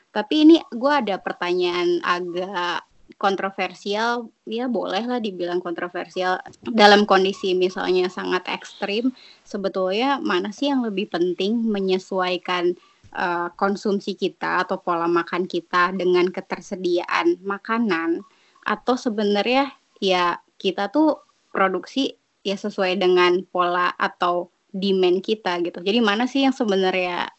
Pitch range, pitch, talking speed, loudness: 180-220 Hz, 195 Hz, 115 wpm, -22 LUFS